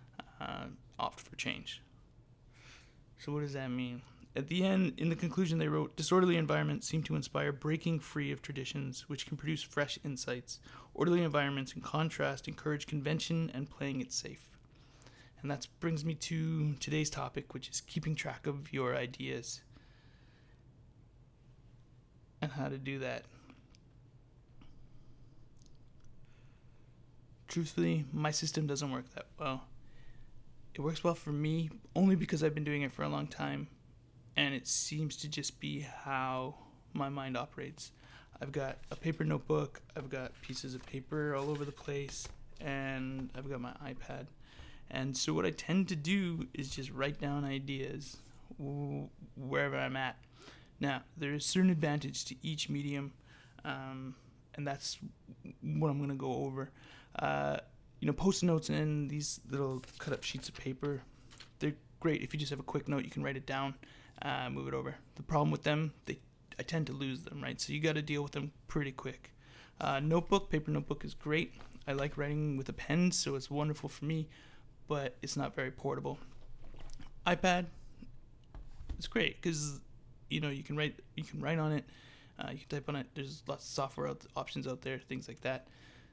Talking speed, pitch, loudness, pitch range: 170 wpm, 140 Hz, -37 LUFS, 125-150 Hz